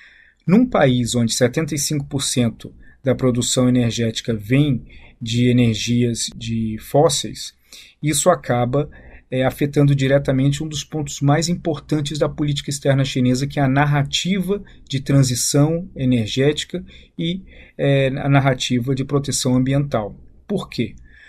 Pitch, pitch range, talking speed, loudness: 140 Hz, 125-150 Hz, 120 wpm, -19 LUFS